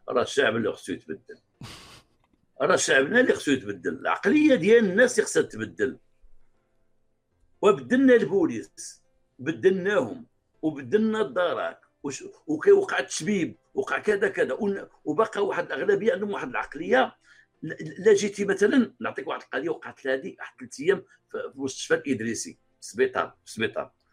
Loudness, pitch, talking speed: -25 LUFS, 255 Hz, 125 wpm